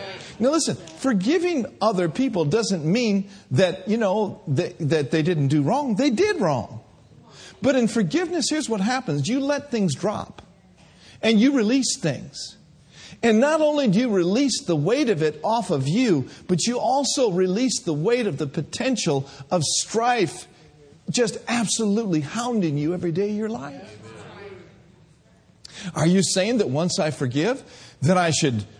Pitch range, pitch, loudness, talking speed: 165-240 Hz, 200 Hz, -22 LUFS, 165 wpm